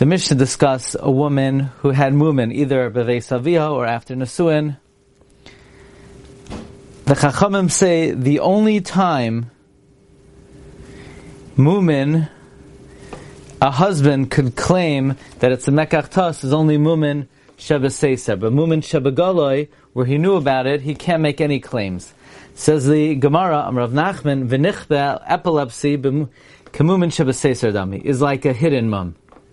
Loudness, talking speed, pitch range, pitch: -17 LUFS, 130 wpm, 130-155 Hz, 145 Hz